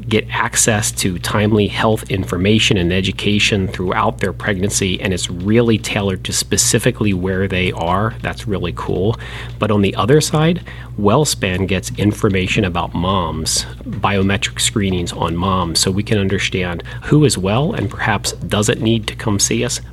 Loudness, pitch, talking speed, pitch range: -16 LUFS, 105 Hz, 155 wpm, 95-120 Hz